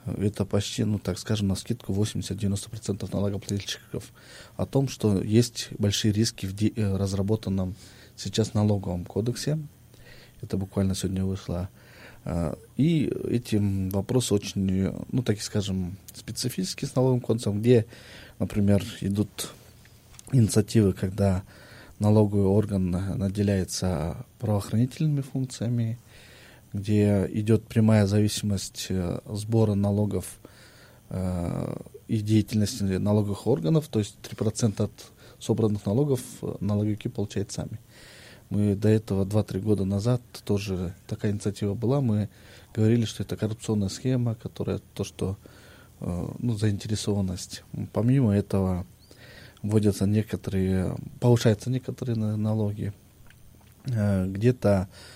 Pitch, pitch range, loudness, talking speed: 105 Hz, 100-115 Hz, -27 LUFS, 100 wpm